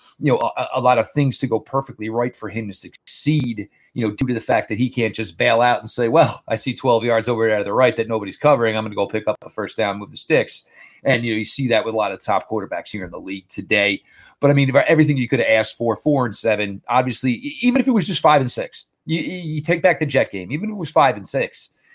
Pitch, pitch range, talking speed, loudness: 120 Hz, 110-145 Hz, 295 wpm, -19 LUFS